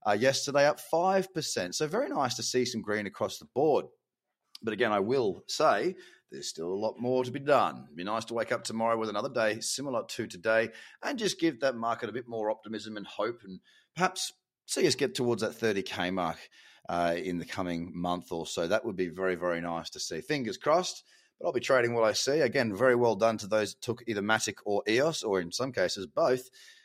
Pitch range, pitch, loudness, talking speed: 105-130 Hz, 115 Hz, -30 LUFS, 230 wpm